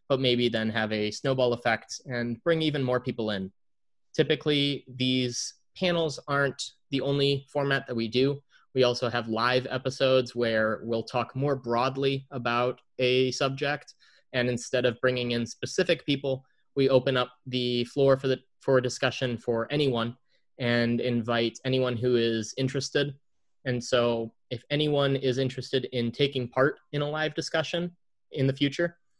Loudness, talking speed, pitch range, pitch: -28 LUFS, 160 wpm, 120-140 Hz, 130 Hz